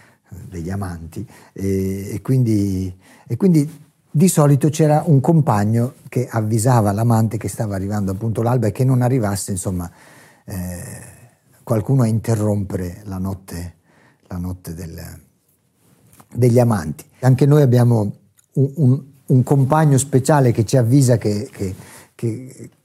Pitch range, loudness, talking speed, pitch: 100-130 Hz, -18 LUFS, 130 wpm, 115 Hz